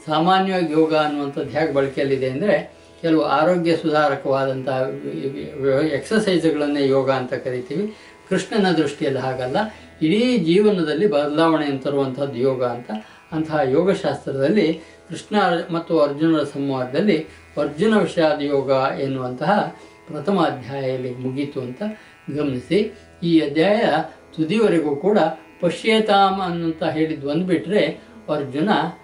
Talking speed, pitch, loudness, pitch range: 95 wpm, 155 Hz, -20 LUFS, 140-175 Hz